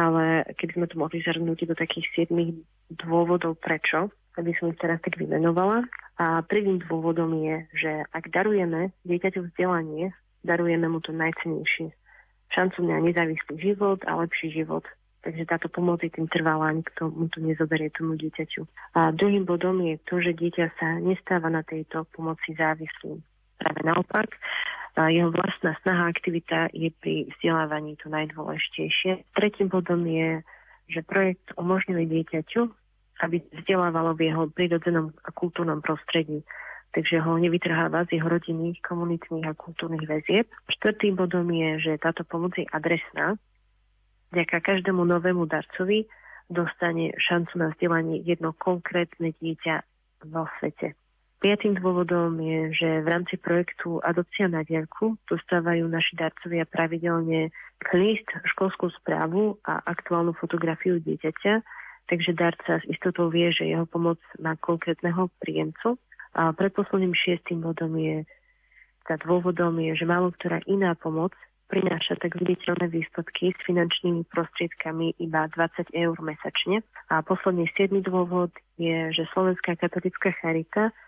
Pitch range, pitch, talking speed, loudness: 160-180 Hz, 170 Hz, 135 wpm, -26 LUFS